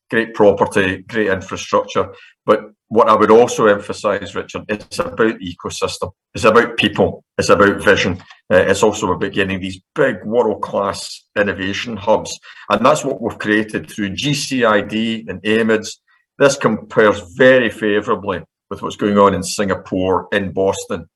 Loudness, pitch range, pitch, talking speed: -16 LUFS, 95-115 Hz, 105 Hz, 145 wpm